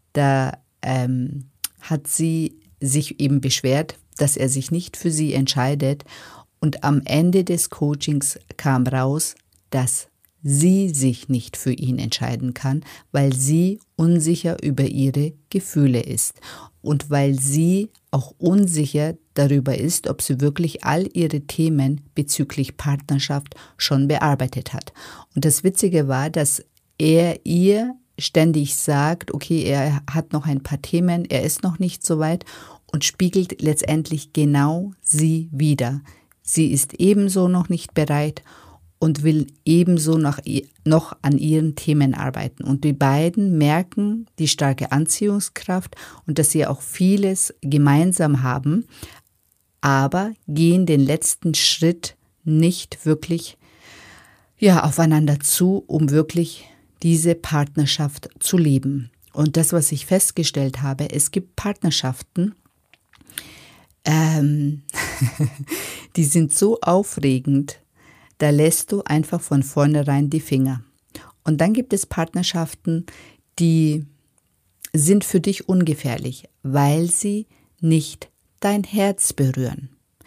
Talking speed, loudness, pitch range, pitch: 125 wpm, -20 LUFS, 140-170 Hz, 150 Hz